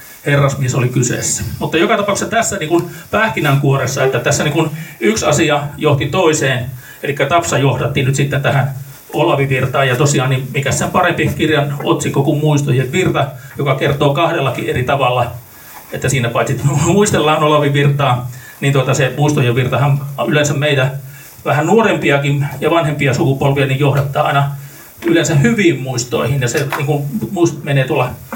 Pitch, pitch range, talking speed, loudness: 140 Hz, 135-155 Hz, 145 wpm, -14 LUFS